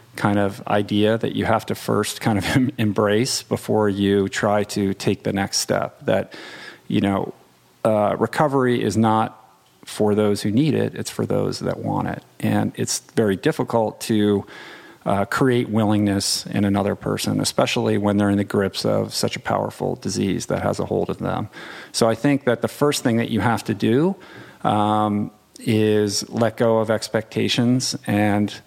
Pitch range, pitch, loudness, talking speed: 105-115 Hz, 105 Hz, -21 LUFS, 175 wpm